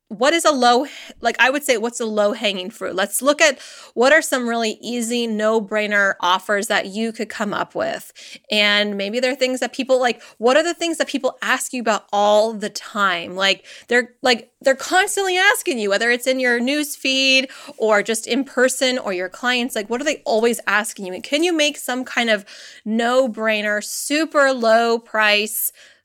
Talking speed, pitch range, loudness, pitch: 195 wpm, 215-270 Hz, -18 LUFS, 240 Hz